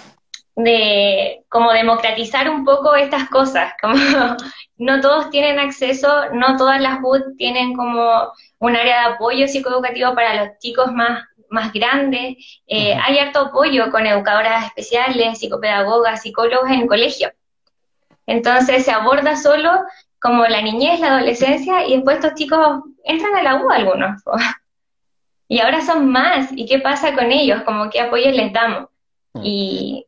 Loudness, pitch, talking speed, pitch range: -15 LUFS, 260 Hz, 150 wpm, 230-280 Hz